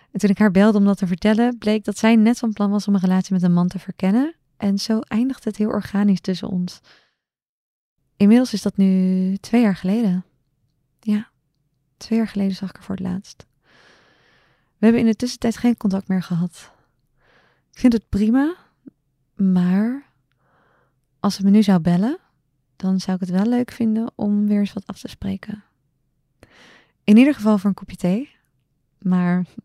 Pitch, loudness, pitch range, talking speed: 200 Hz, -19 LUFS, 185-220 Hz, 185 wpm